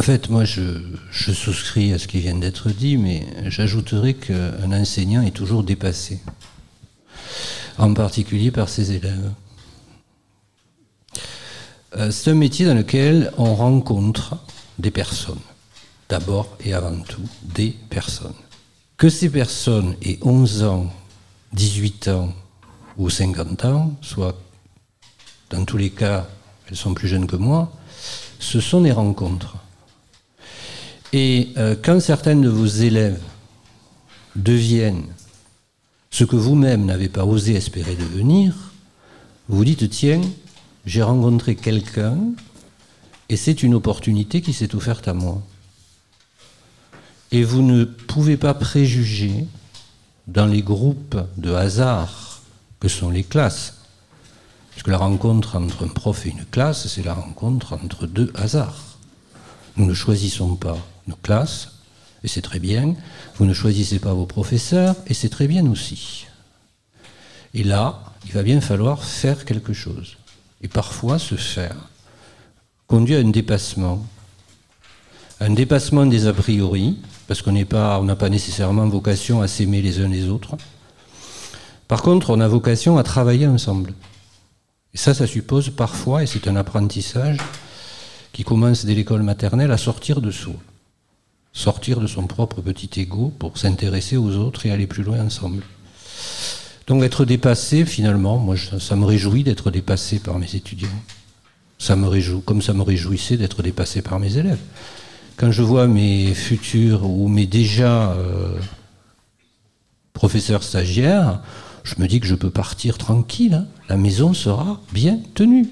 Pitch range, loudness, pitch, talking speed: 100-120 Hz, -19 LUFS, 105 Hz, 145 wpm